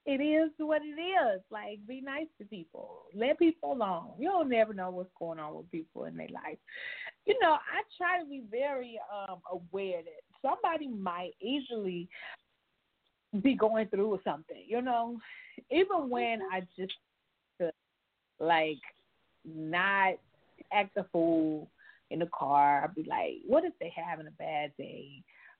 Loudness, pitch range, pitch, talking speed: -33 LUFS, 180-300 Hz, 220 Hz, 150 wpm